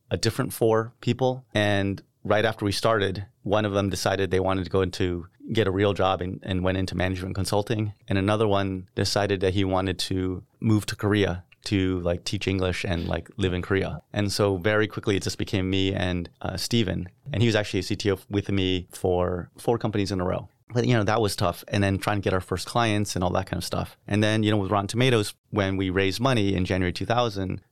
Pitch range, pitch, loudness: 95-110 Hz, 100 Hz, -25 LUFS